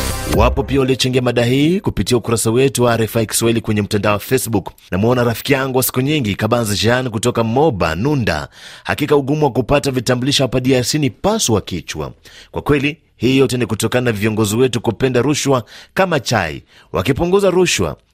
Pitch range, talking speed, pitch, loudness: 115-140 Hz, 165 wpm, 125 Hz, -16 LUFS